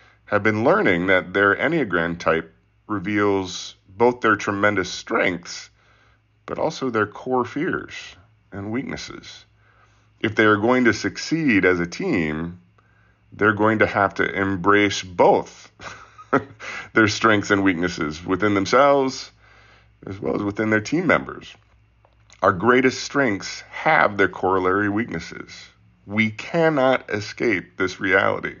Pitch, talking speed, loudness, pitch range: 105 Hz, 125 wpm, -20 LUFS, 100-110 Hz